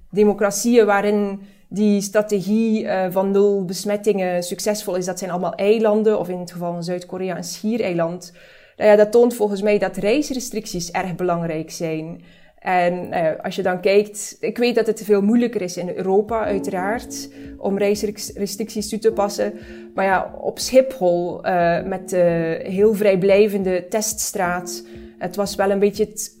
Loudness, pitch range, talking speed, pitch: -20 LUFS, 180-210 Hz, 160 wpm, 200 Hz